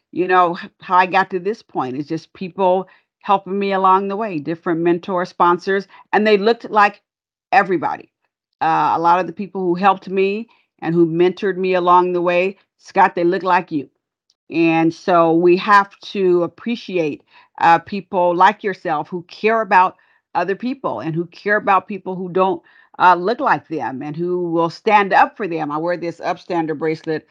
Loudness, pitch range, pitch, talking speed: -17 LUFS, 170-195 Hz, 185 Hz, 180 wpm